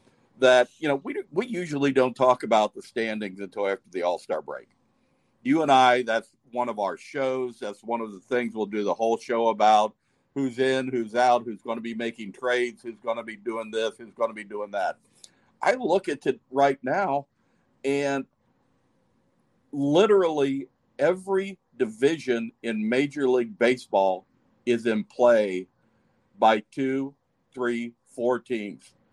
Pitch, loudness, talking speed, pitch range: 120 Hz, -25 LUFS, 155 wpm, 110-135 Hz